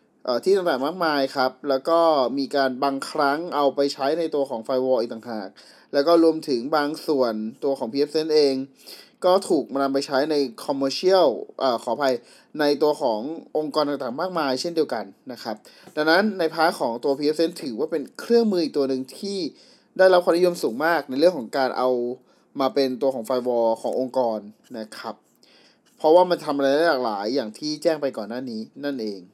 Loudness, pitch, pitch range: -23 LUFS, 140 Hz, 130-165 Hz